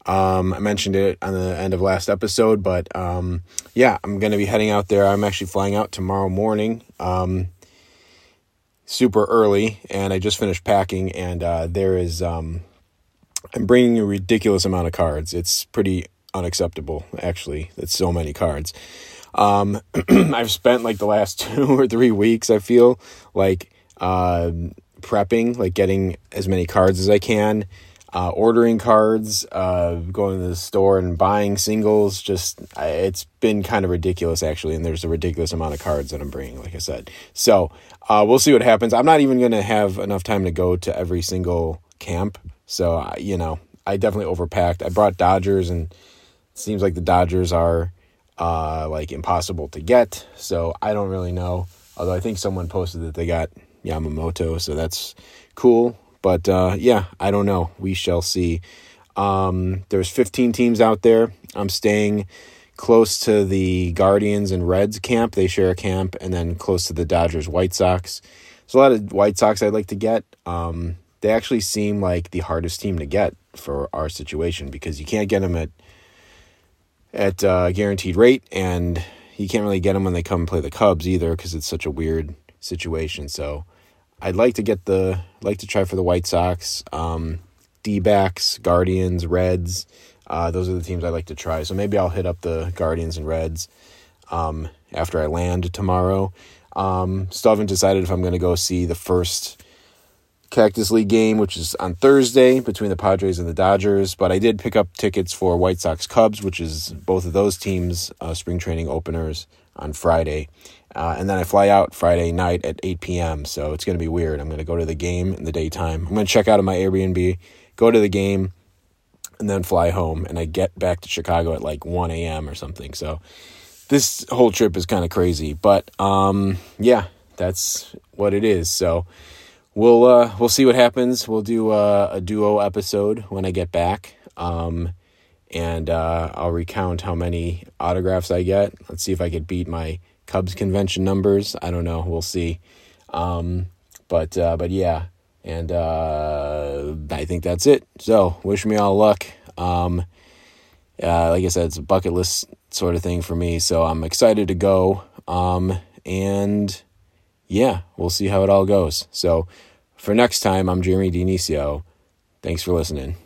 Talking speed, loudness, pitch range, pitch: 185 wpm, -20 LUFS, 85-100 Hz, 90 Hz